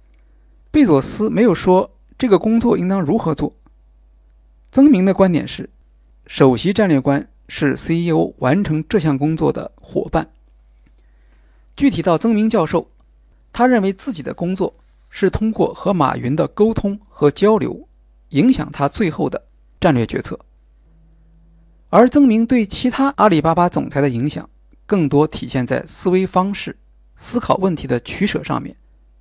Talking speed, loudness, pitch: 225 characters per minute, -17 LUFS, 165 Hz